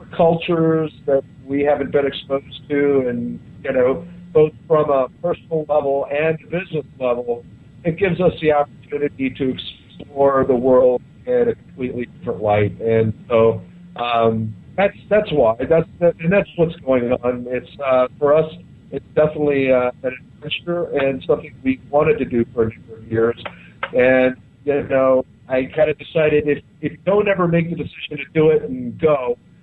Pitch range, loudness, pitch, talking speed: 125-160 Hz, -19 LUFS, 140 Hz, 170 wpm